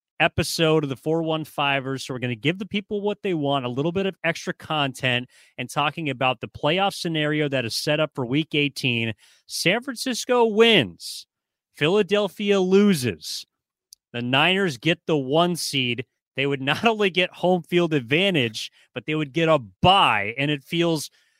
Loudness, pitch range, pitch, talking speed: -22 LUFS, 135-180 Hz, 155 Hz, 170 wpm